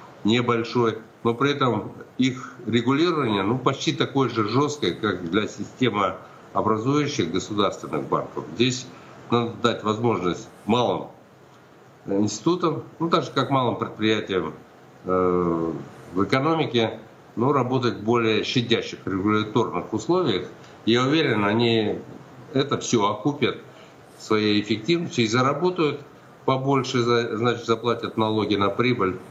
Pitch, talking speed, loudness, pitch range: 115 Hz, 115 wpm, -23 LUFS, 105-135 Hz